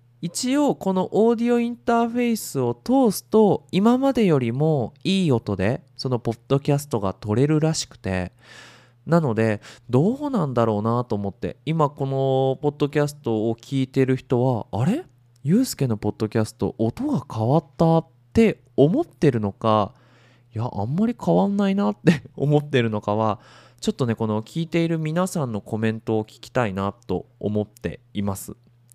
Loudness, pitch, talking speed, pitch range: -22 LUFS, 130 Hz, 340 characters per minute, 115-165 Hz